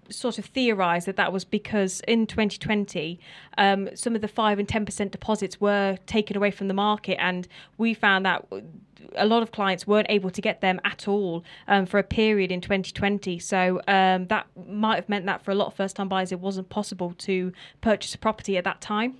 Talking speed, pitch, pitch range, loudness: 215 wpm, 200 Hz, 185-210 Hz, -25 LUFS